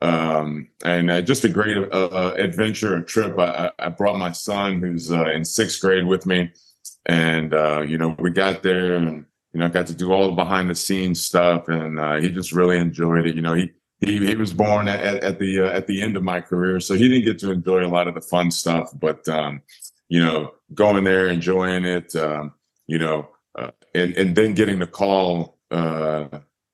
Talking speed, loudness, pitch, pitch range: 220 wpm, -21 LUFS, 90 Hz, 85-95 Hz